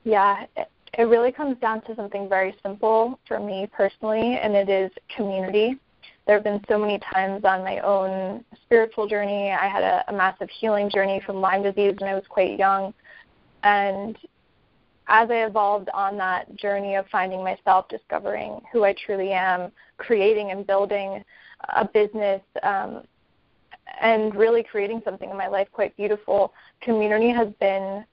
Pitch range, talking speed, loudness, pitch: 195-220 Hz, 160 wpm, -23 LUFS, 200 Hz